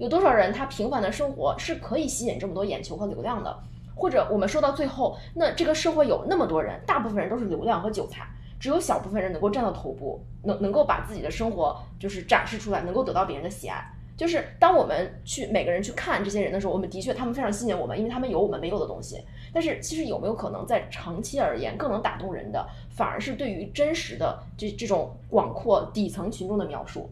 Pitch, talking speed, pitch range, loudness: 210 Hz, 375 characters per minute, 190-285 Hz, -27 LUFS